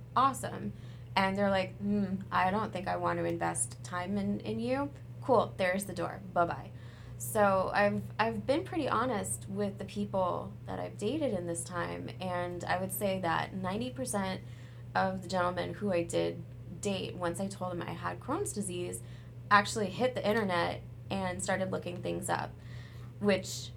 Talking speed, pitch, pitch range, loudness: 170 wpm, 125 Hz, 115-190 Hz, -33 LUFS